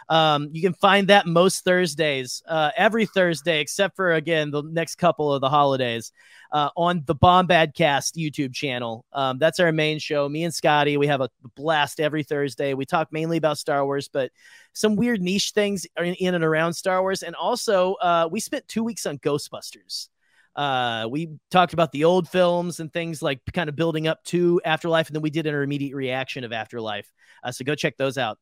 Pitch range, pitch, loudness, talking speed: 145-175 Hz, 160 Hz, -22 LUFS, 200 wpm